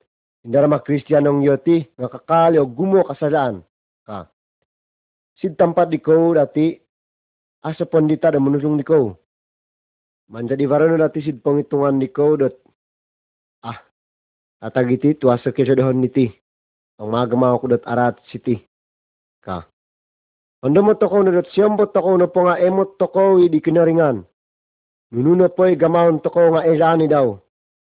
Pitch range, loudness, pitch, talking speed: 120-165 Hz, -17 LUFS, 145 Hz, 140 wpm